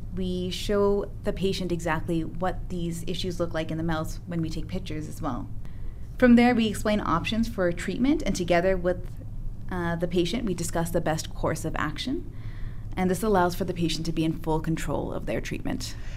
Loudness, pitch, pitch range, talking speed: -27 LUFS, 170 Hz, 155-185 Hz, 195 wpm